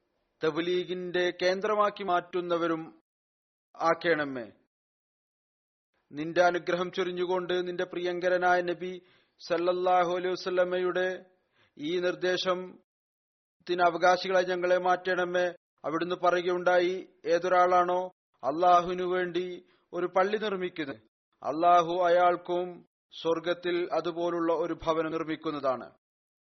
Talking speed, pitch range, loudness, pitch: 70 wpm, 175-180 Hz, -28 LUFS, 180 Hz